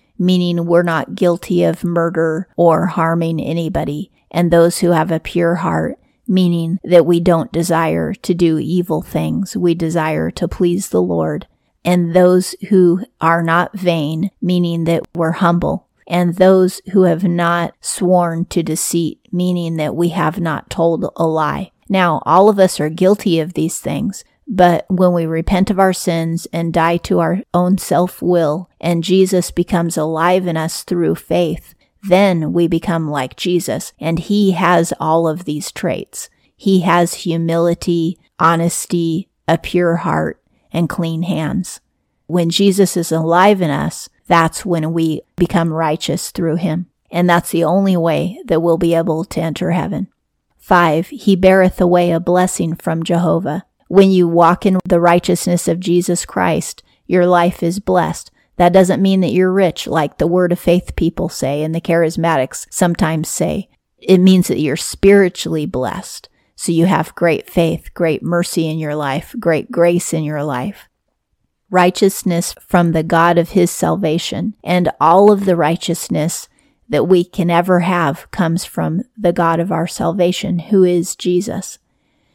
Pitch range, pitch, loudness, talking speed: 165-185 Hz, 175 Hz, -15 LUFS, 160 wpm